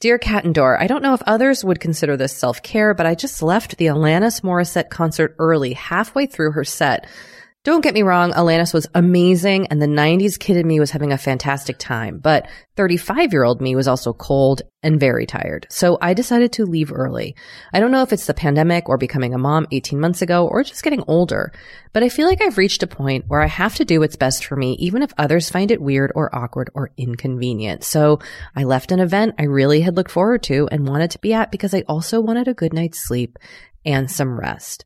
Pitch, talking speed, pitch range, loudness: 165 Hz, 230 wpm, 140-200 Hz, -17 LUFS